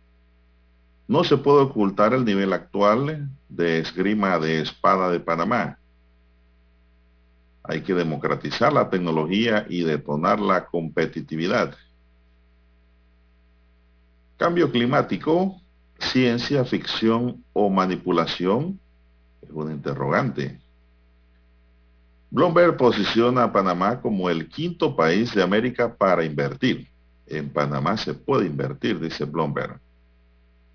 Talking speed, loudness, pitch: 100 wpm, -22 LUFS, 75 Hz